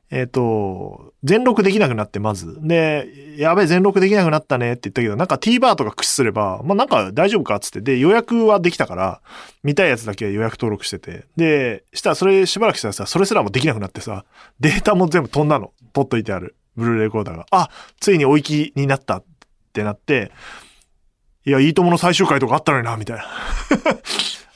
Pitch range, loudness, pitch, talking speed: 110-180 Hz, -18 LUFS, 140 Hz, 435 characters per minute